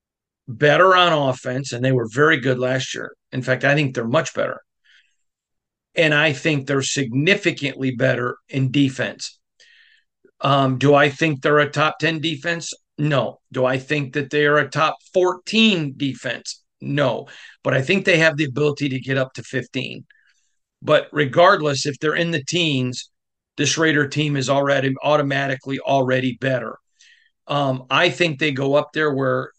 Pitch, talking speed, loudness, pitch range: 145 Hz, 165 wpm, -19 LUFS, 135-155 Hz